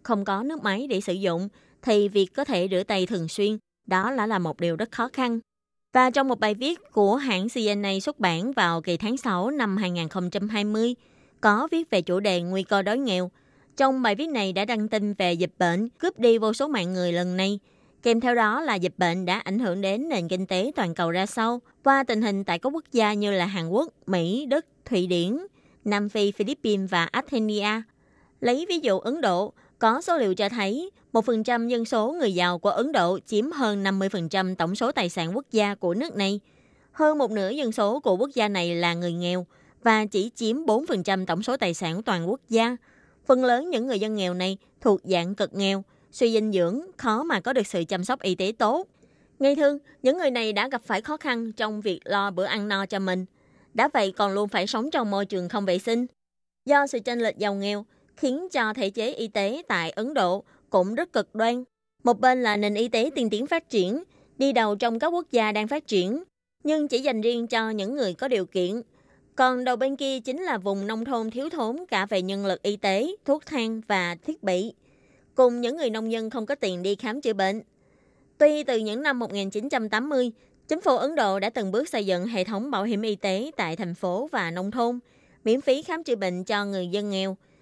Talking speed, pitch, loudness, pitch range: 225 wpm, 215 Hz, -25 LUFS, 190-250 Hz